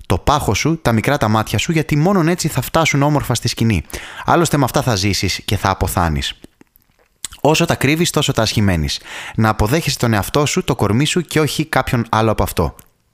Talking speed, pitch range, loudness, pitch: 200 wpm, 105-150 Hz, -16 LUFS, 125 Hz